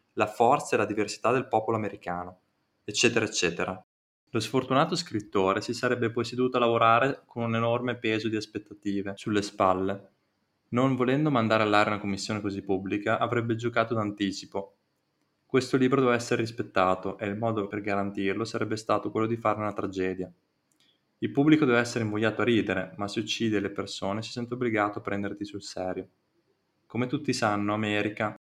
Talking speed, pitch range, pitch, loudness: 165 wpm, 100-120 Hz, 105 Hz, -28 LUFS